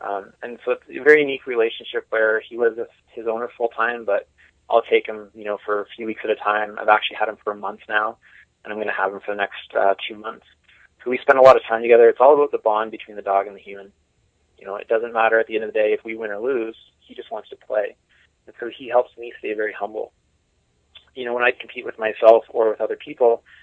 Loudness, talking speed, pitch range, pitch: -20 LUFS, 275 wpm, 105-140 Hz, 115 Hz